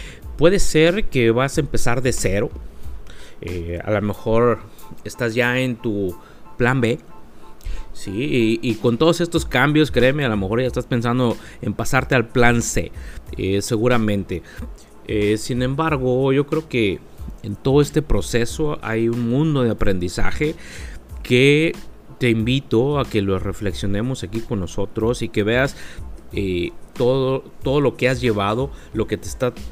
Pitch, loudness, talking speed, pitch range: 115 Hz, -20 LUFS, 155 wpm, 105-130 Hz